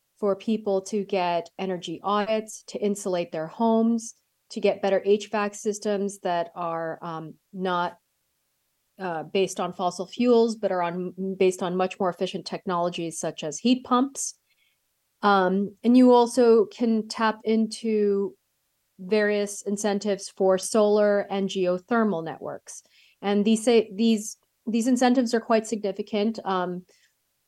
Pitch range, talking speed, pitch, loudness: 185-220 Hz, 130 wpm, 200 Hz, -25 LUFS